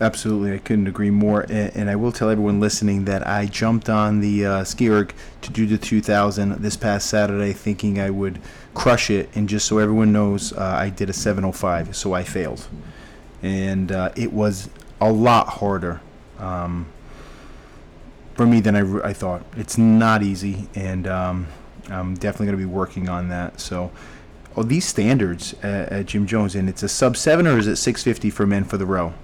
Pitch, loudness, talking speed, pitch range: 100 Hz, -20 LUFS, 195 wpm, 95-110 Hz